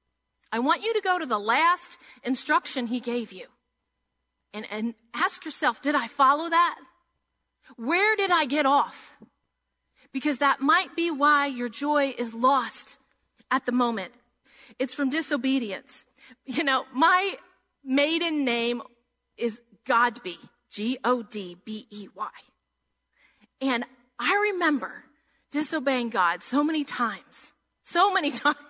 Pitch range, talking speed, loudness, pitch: 235-300 Hz, 125 wpm, -25 LUFS, 265 Hz